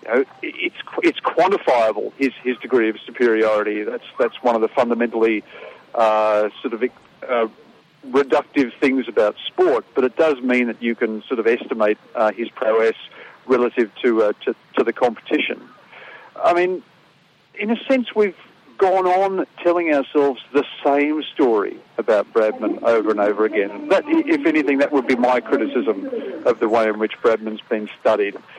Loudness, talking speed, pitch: -19 LUFS, 165 wpm, 140 Hz